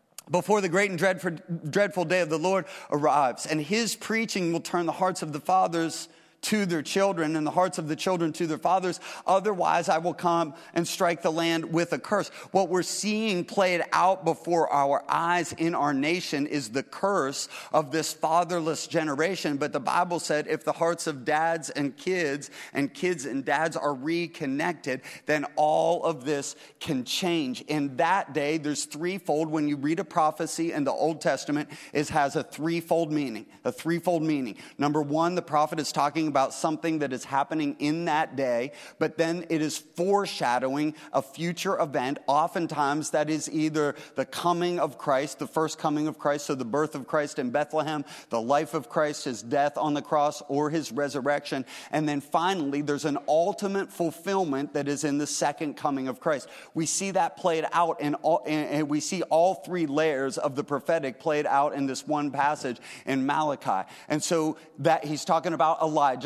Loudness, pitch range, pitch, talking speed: -27 LUFS, 145-170 Hz, 155 Hz, 185 wpm